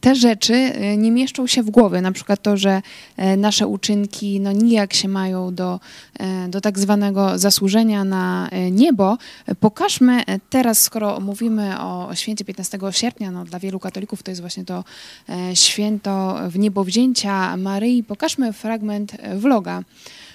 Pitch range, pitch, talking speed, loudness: 190-225 Hz, 205 Hz, 140 wpm, -18 LUFS